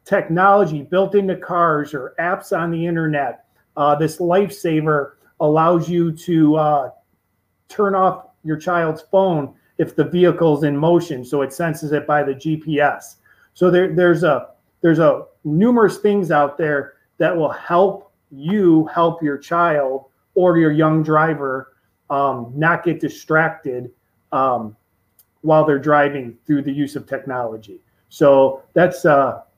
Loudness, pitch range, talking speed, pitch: -17 LUFS, 140-175 Hz, 140 wpm, 155 Hz